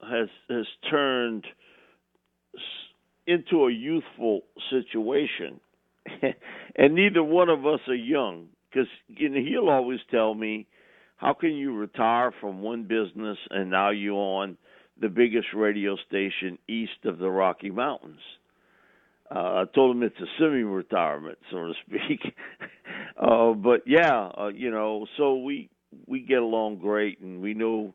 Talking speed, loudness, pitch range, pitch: 140 wpm, -26 LUFS, 105-135 Hz, 115 Hz